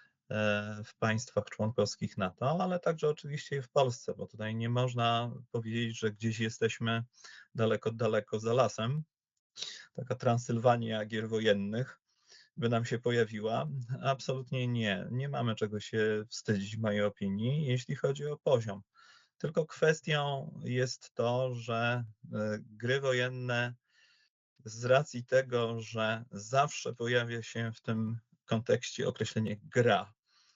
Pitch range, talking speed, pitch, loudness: 110-130 Hz, 125 wpm, 115 Hz, -33 LUFS